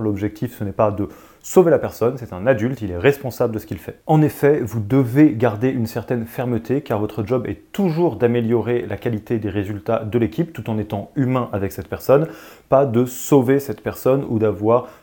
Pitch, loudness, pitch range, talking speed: 120 Hz, -20 LUFS, 105-130 Hz, 210 wpm